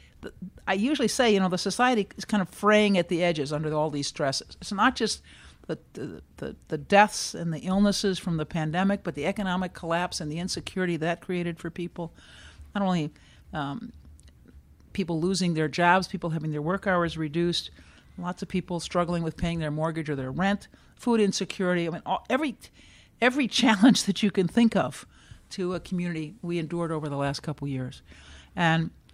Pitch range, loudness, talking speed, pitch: 155-195 Hz, -27 LUFS, 185 wpm, 175 Hz